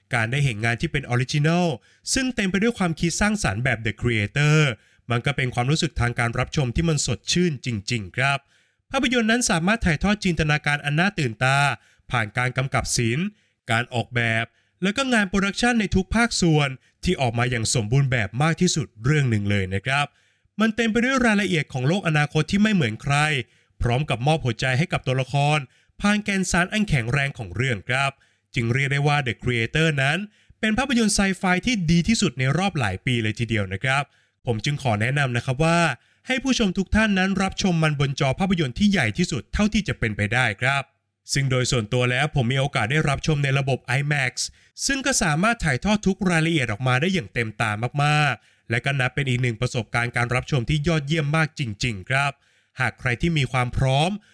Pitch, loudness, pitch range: 140 Hz, -22 LUFS, 120-175 Hz